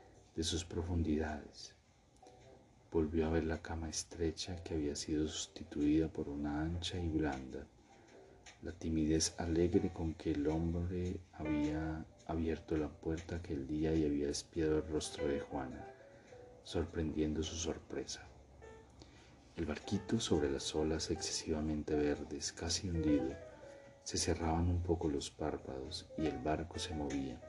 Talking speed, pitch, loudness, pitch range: 135 wpm, 80 Hz, -38 LUFS, 75-85 Hz